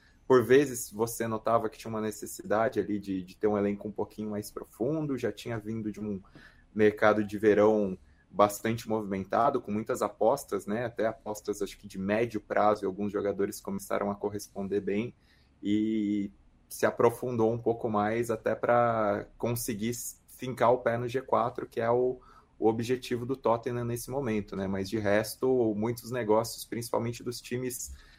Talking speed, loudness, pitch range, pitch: 165 wpm, -30 LUFS, 105-120 Hz, 110 Hz